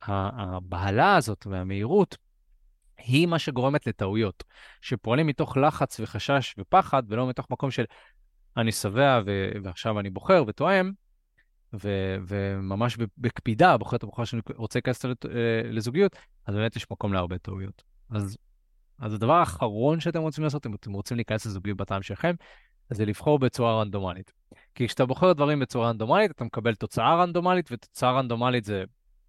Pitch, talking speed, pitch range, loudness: 115 Hz, 145 wpm, 100-135 Hz, -26 LUFS